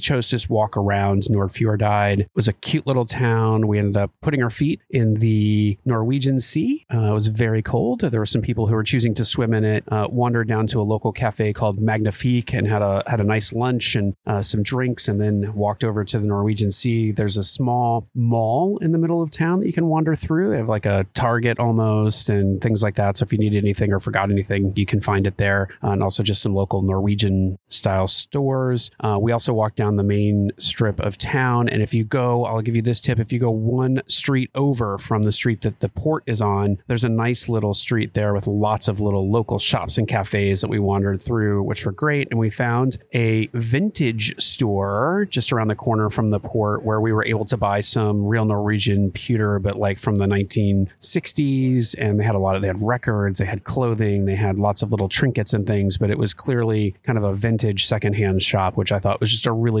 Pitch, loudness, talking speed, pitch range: 110 Hz, -19 LUFS, 230 wpm, 105-120 Hz